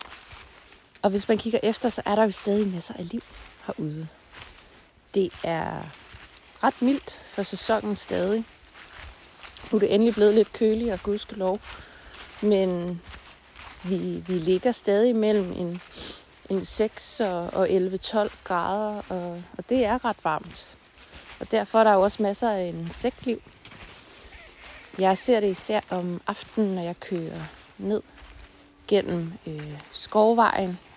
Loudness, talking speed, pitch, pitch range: -25 LUFS, 140 wpm, 200 Hz, 180-220 Hz